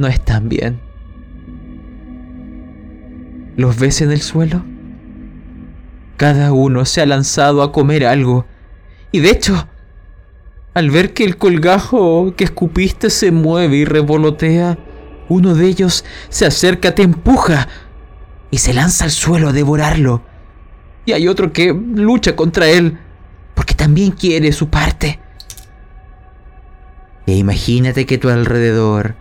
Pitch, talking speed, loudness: 145 Hz, 125 wpm, -13 LUFS